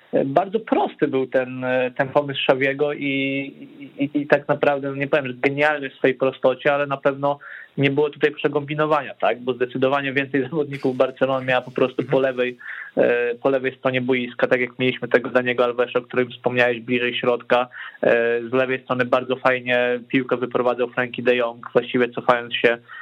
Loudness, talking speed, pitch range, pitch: -21 LUFS, 175 wpm, 125-145 Hz, 130 Hz